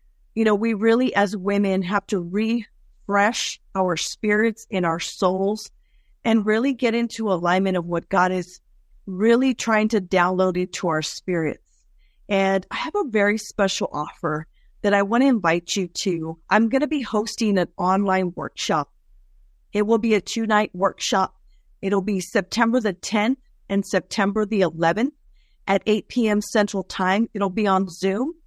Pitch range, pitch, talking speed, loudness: 185-220 Hz, 200 Hz, 160 wpm, -22 LUFS